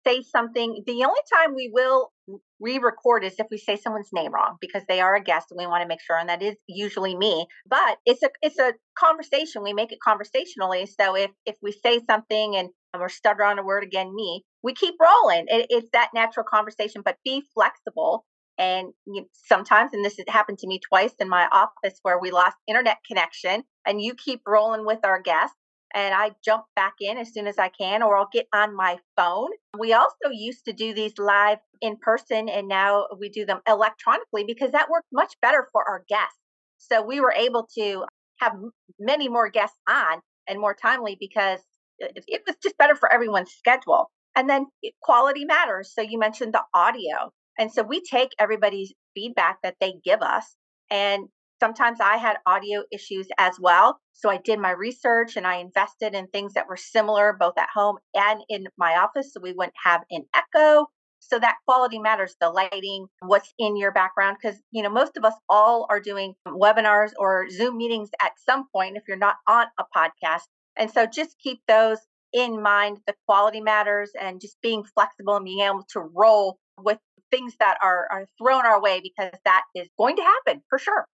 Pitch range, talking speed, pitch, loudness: 195-235 Hz, 200 wpm, 215 Hz, -22 LUFS